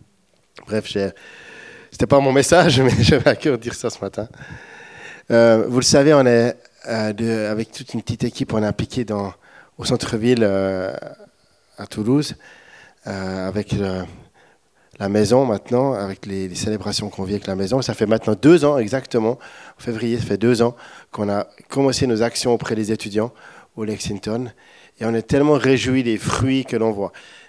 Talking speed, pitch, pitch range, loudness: 180 wpm, 115 Hz, 105-125 Hz, -19 LUFS